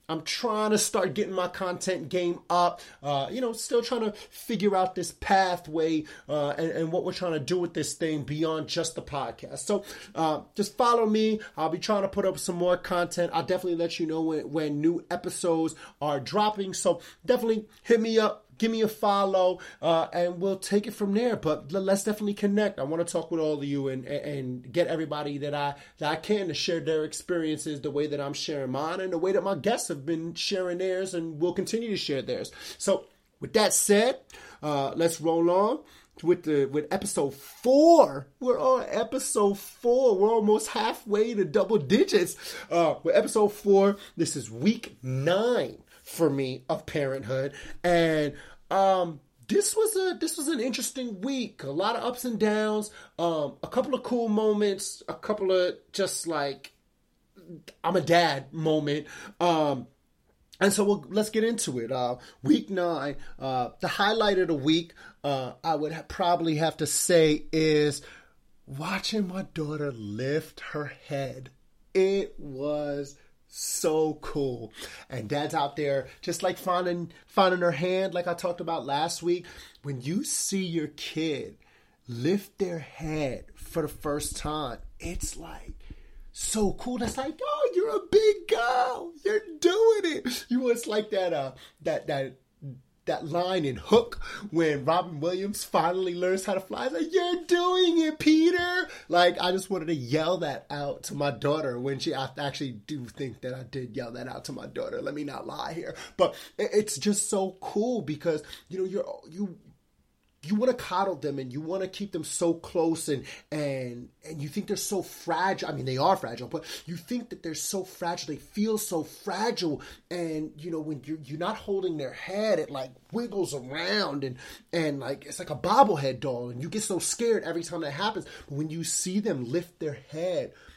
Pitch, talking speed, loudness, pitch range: 175 Hz, 190 wpm, -28 LUFS, 150-210 Hz